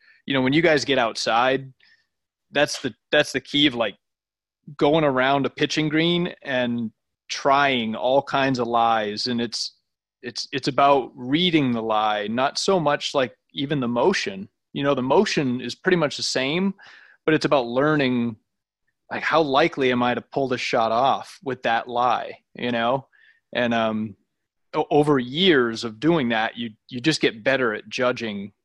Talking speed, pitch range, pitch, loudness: 170 wpm, 120-150 Hz, 130 Hz, -22 LUFS